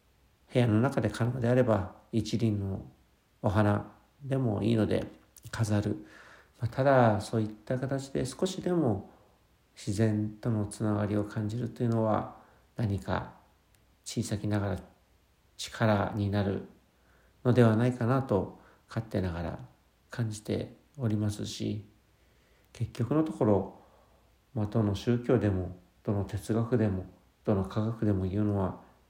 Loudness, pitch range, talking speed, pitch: -30 LUFS, 100-115 Hz, 250 characters per minute, 105 Hz